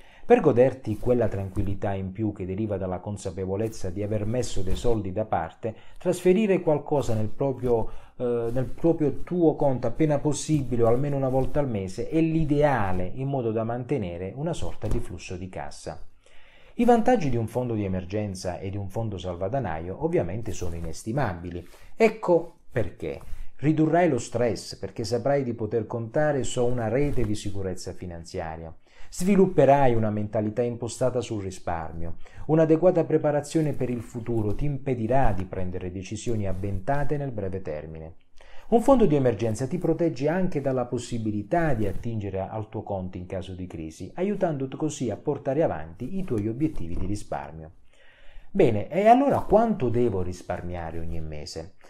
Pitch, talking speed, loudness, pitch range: 115 Hz, 155 wpm, -26 LUFS, 95-145 Hz